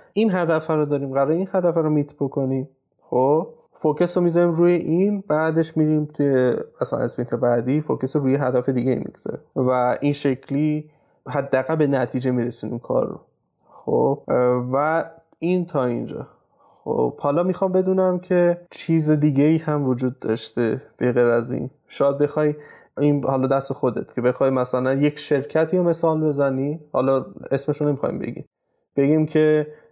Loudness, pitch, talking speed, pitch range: -21 LUFS, 145 Hz, 155 wpm, 130-160 Hz